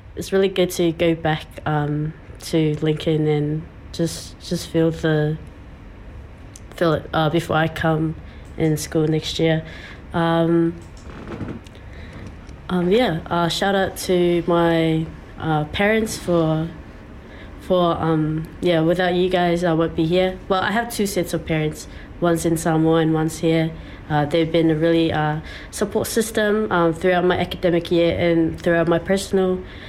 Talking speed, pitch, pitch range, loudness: 150 wpm, 165 Hz, 155-175 Hz, -20 LUFS